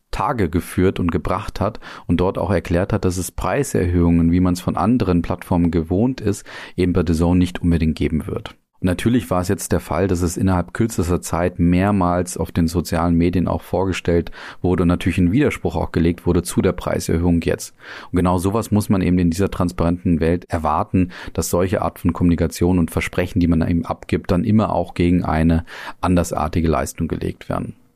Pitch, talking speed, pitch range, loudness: 90 Hz, 195 wpm, 85-95 Hz, -19 LUFS